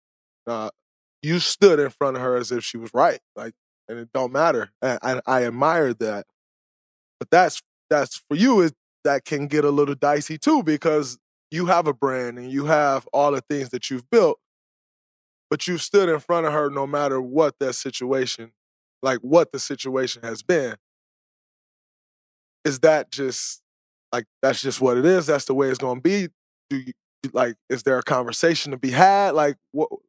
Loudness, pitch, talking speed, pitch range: -22 LUFS, 140 Hz, 190 wpm, 125-155 Hz